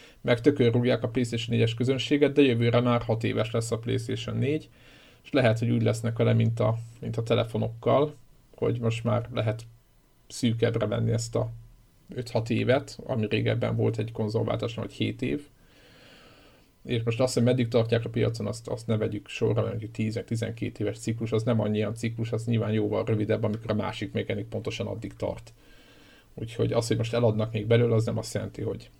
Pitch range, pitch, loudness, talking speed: 110-120 Hz, 115 Hz, -27 LUFS, 185 wpm